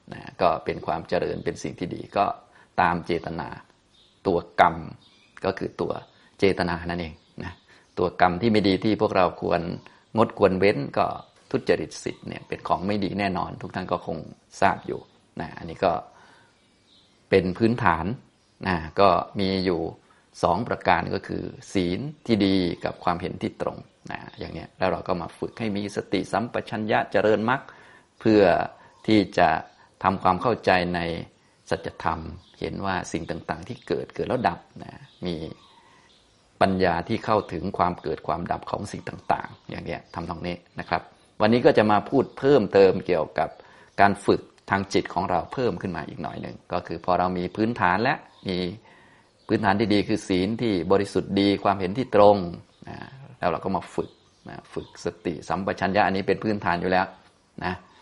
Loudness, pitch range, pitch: -25 LUFS, 90-105 Hz, 95 Hz